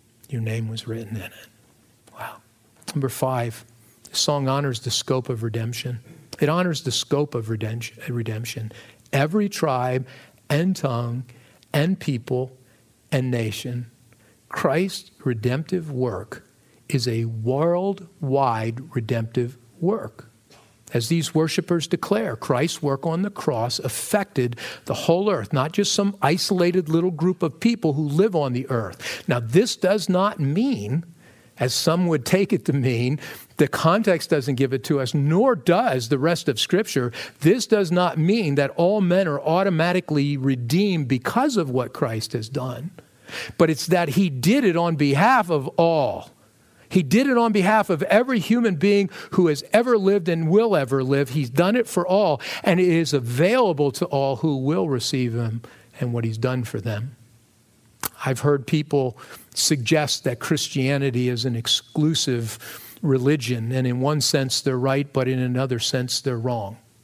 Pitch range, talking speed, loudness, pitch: 125-175 Hz, 155 wpm, -22 LUFS, 140 Hz